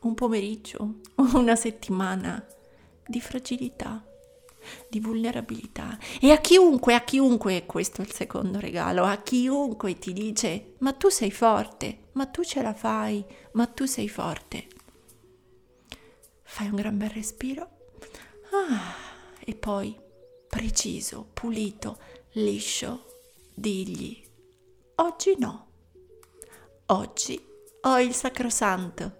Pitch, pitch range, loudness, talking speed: 230 Hz, 205-270 Hz, -26 LUFS, 110 wpm